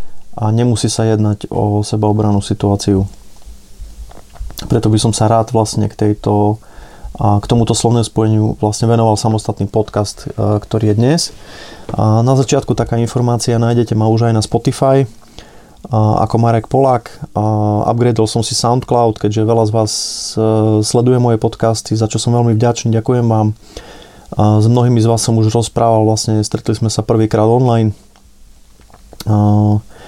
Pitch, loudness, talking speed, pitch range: 110 Hz, -14 LUFS, 140 wpm, 105-115 Hz